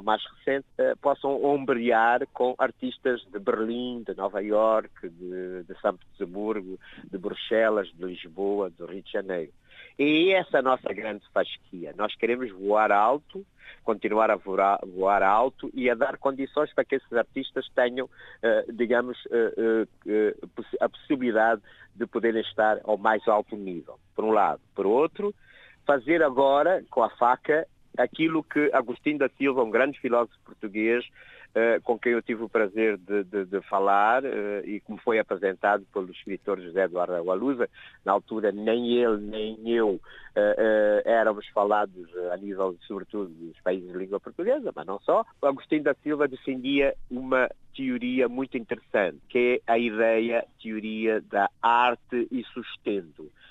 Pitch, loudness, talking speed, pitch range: 115 Hz, -26 LUFS, 155 wpm, 105-130 Hz